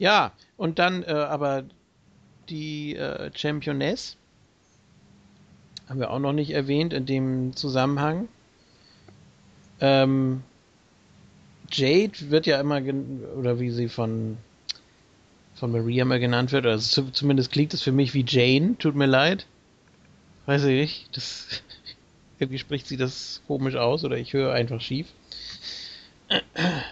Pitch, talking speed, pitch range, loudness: 135 Hz, 135 wpm, 125-150 Hz, -25 LUFS